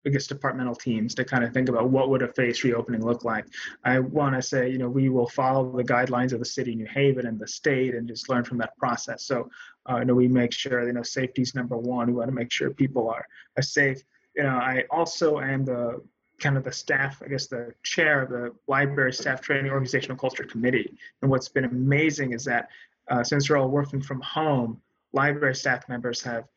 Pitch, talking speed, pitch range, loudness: 130 Hz, 230 wpm, 120-135 Hz, -25 LUFS